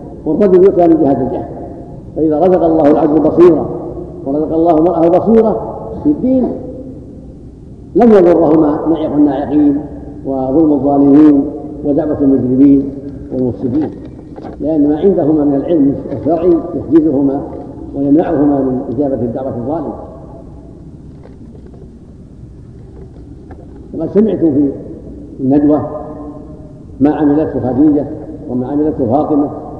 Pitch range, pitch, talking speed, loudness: 140-165 Hz, 150 Hz, 95 wpm, -12 LUFS